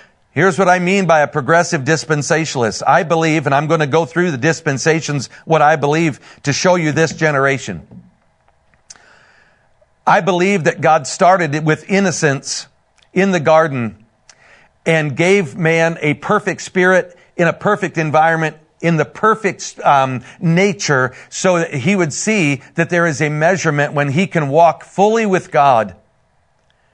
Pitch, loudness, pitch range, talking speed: 160 Hz, -15 LUFS, 145-180 Hz, 150 wpm